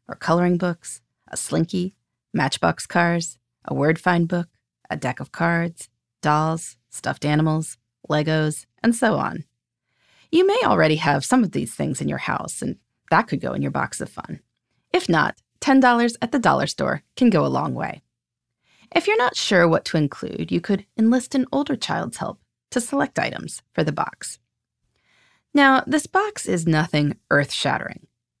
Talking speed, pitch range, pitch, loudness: 170 wpm, 150-250 Hz, 170 Hz, -21 LUFS